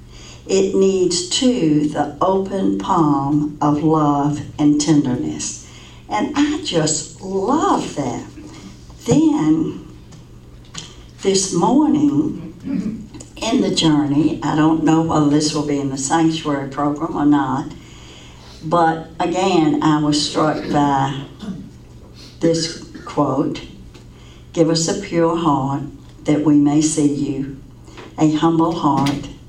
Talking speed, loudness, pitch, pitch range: 110 wpm, -18 LUFS, 155 Hz, 145-170 Hz